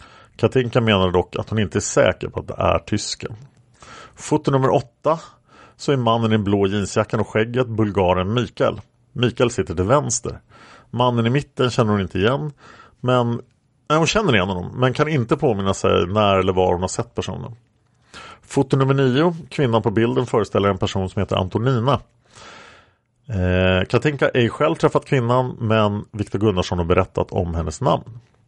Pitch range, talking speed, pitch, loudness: 100-130 Hz, 175 wpm, 115 Hz, -20 LUFS